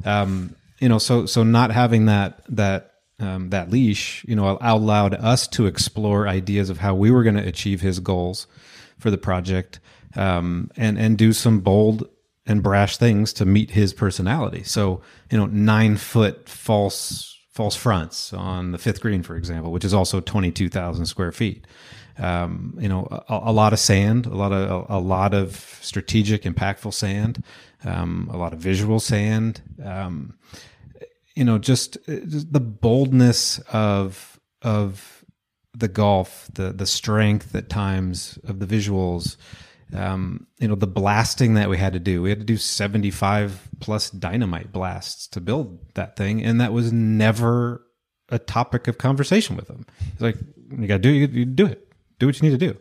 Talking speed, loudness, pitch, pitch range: 180 wpm, -21 LUFS, 105 Hz, 95-115 Hz